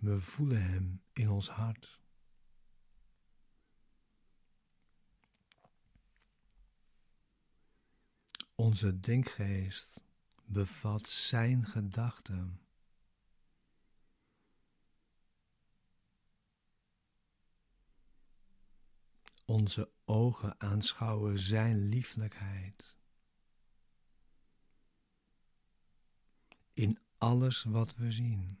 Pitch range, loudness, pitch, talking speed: 100-115 Hz, -35 LUFS, 110 Hz, 45 wpm